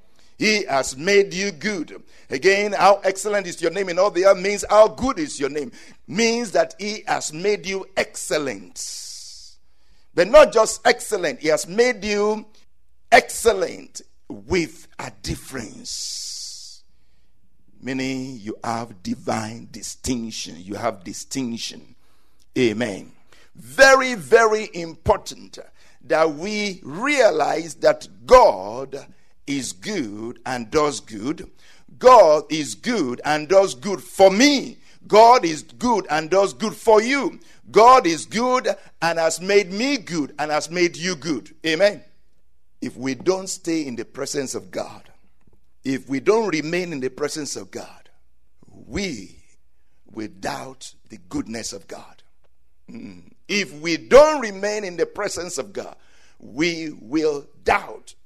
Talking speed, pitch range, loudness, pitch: 135 wpm, 135-210 Hz, -20 LUFS, 175 Hz